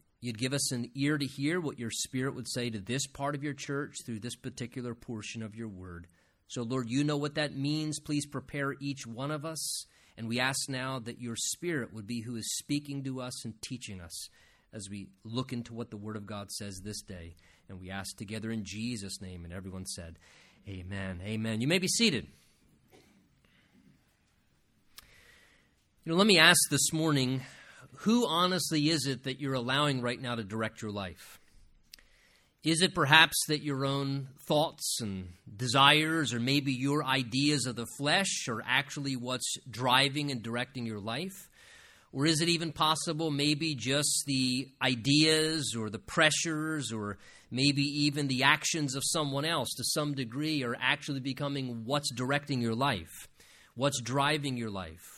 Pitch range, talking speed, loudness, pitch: 115-150 Hz, 175 wpm, -30 LUFS, 130 Hz